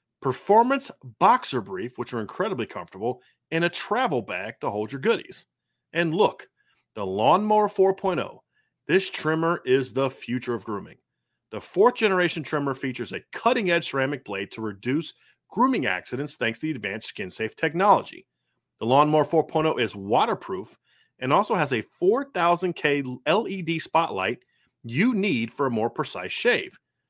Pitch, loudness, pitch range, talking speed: 155 Hz, -25 LUFS, 130-185 Hz, 150 wpm